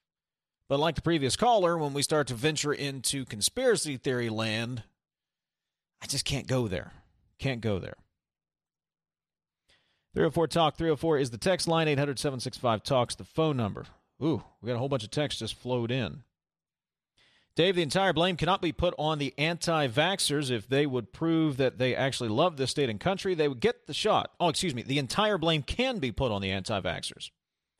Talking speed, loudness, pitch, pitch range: 180 wpm, -29 LUFS, 140 Hz, 120-165 Hz